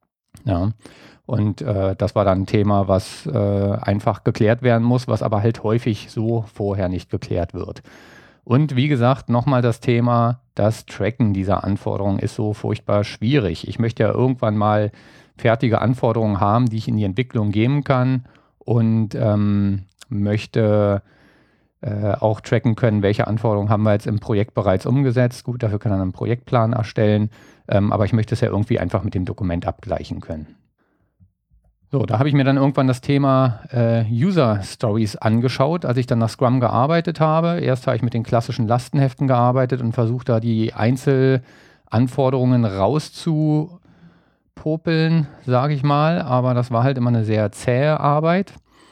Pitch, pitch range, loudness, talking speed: 115 Hz, 105-130 Hz, -19 LUFS, 160 wpm